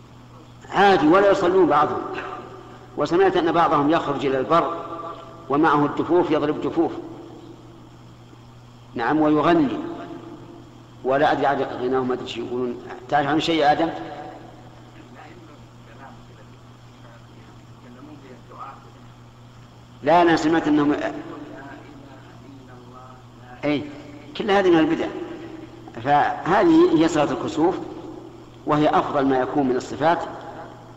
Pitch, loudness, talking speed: 150 Hz, -20 LUFS, 85 wpm